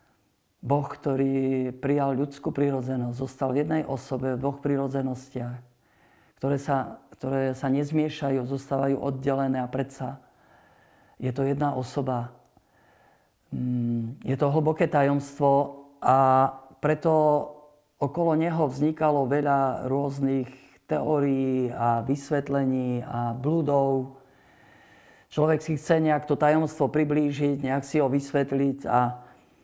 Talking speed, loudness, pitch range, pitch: 105 wpm, -26 LUFS, 130-145 Hz, 135 Hz